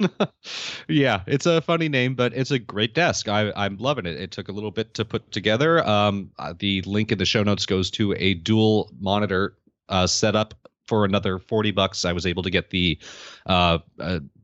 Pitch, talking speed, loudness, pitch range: 105 Hz, 200 wpm, -23 LUFS, 95-115 Hz